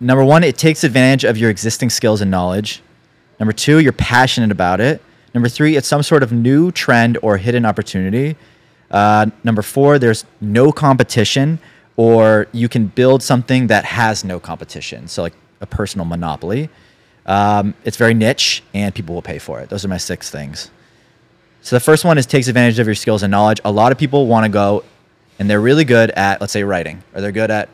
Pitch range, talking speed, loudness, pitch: 105-130 Hz, 205 wpm, -14 LUFS, 115 Hz